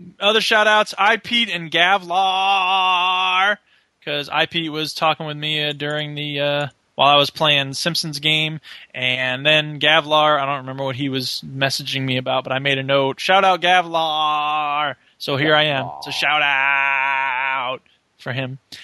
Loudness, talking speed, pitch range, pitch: -18 LUFS, 155 wpm, 135-175 Hz, 150 Hz